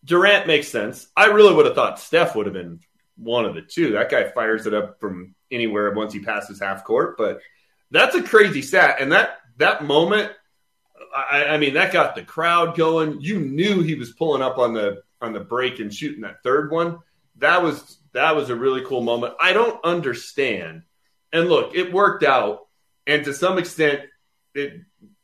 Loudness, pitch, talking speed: -19 LUFS, 145 Hz, 195 wpm